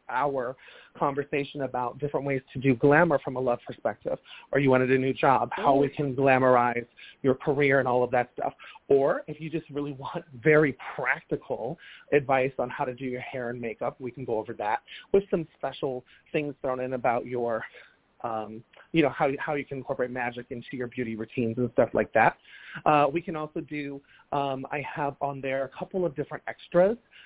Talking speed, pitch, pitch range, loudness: 200 wpm, 135 Hz, 125-150 Hz, -27 LUFS